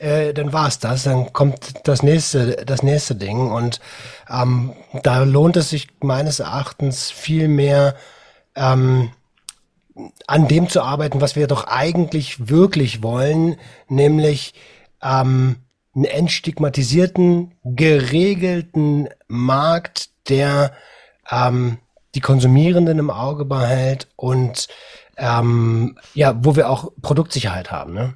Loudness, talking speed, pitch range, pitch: -17 LUFS, 115 wpm, 130-150 Hz, 140 Hz